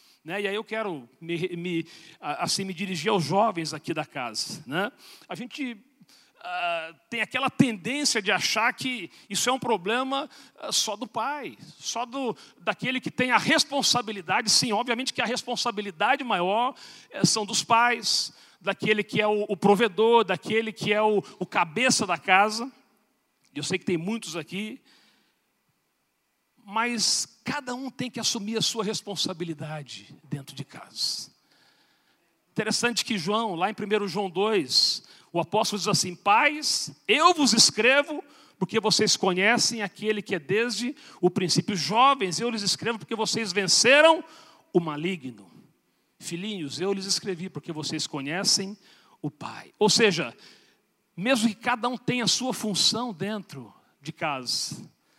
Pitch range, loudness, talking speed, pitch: 185-240 Hz, -25 LUFS, 150 wpm, 210 Hz